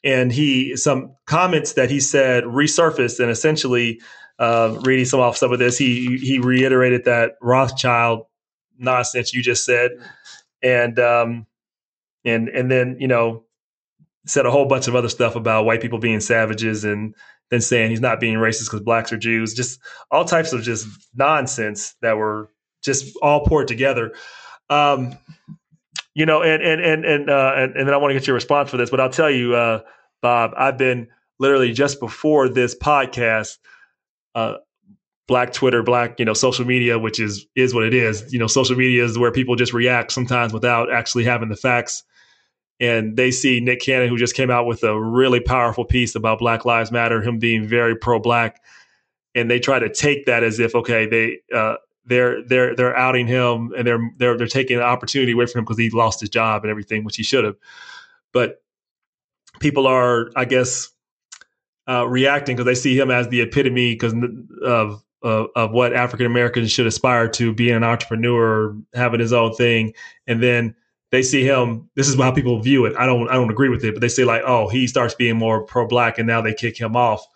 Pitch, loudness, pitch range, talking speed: 120 Hz, -18 LUFS, 115-130 Hz, 195 wpm